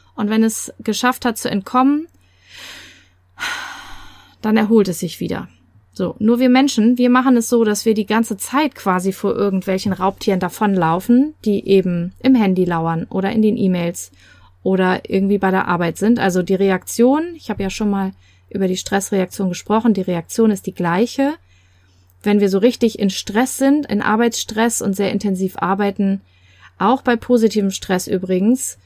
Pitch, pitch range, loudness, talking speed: 200 Hz, 185-230 Hz, -17 LUFS, 165 wpm